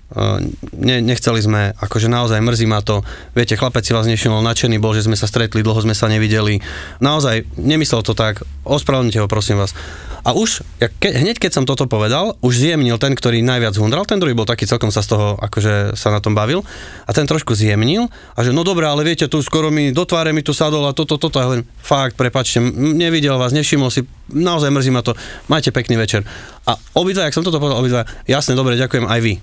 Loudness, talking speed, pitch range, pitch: -16 LUFS, 225 wpm, 110-145 Hz, 120 Hz